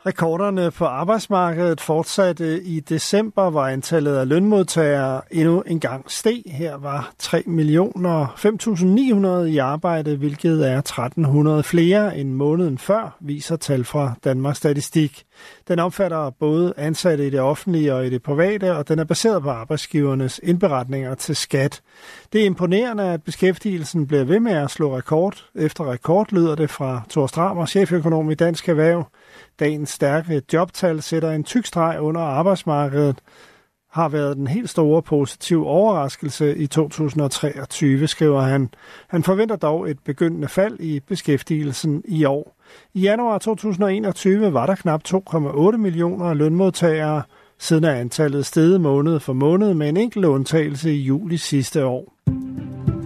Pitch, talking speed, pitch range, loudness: 160 Hz, 145 wpm, 145-180 Hz, -20 LUFS